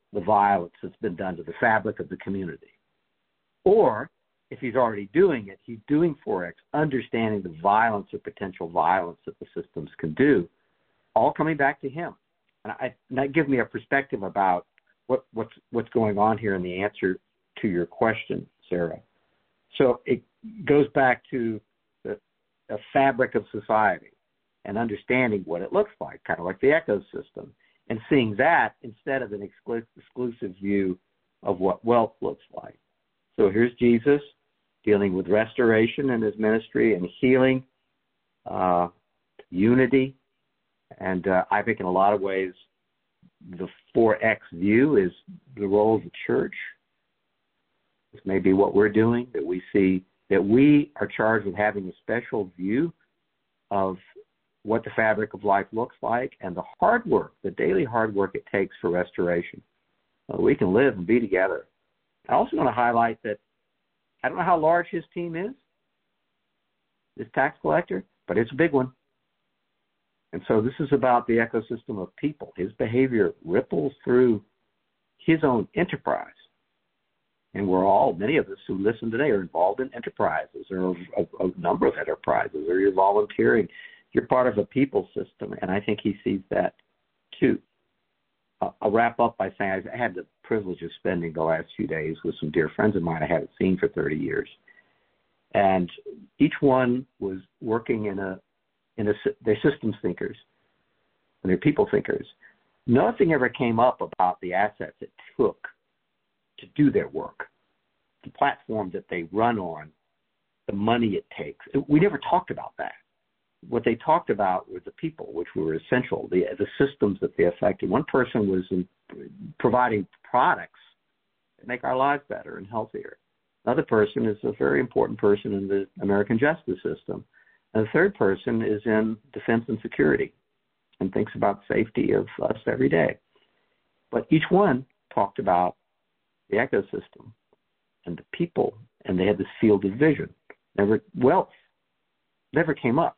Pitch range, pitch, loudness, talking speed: 100-135 Hz, 115 Hz, -25 LUFS, 165 wpm